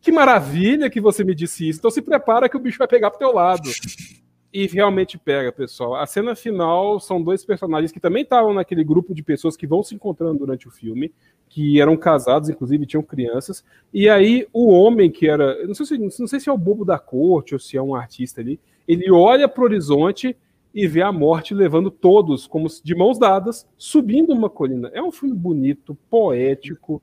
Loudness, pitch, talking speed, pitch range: -18 LUFS, 180 Hz, 205 wpm, 150-220 Hz